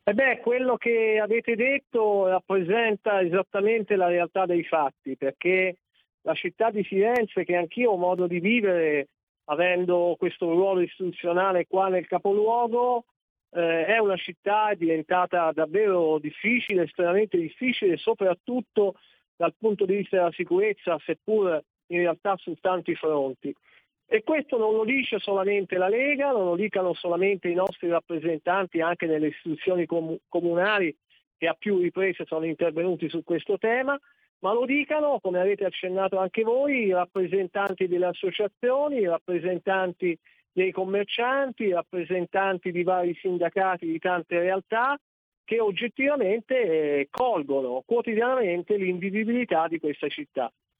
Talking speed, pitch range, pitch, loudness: 130 wpm, 175-220 Hz, 185 Hz, -25 LUFS